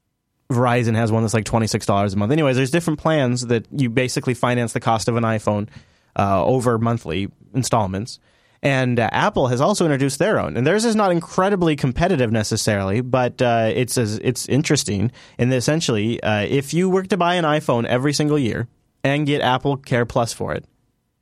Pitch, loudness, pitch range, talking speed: 125 Hz, -20 LUFS, 115-145 Hz, 185 wpm